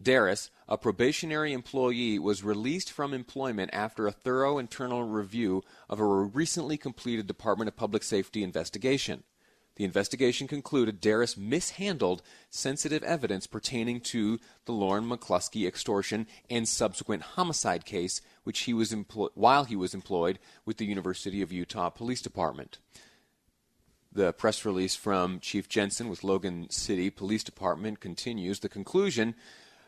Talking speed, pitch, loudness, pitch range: 135 wpm, 110 Hz, -31 LUFS, 100-130 Hz